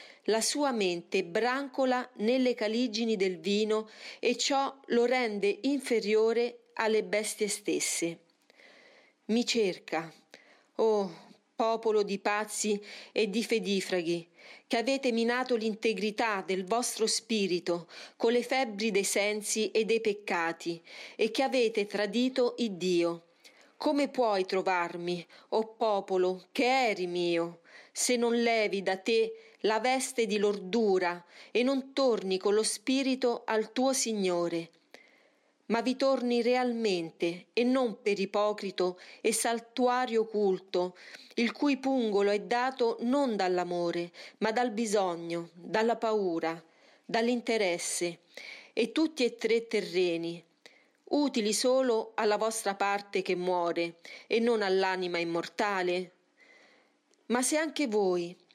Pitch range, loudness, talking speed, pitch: 185-240 Hz, -30 LUFS, 120 wpm, 215 Hz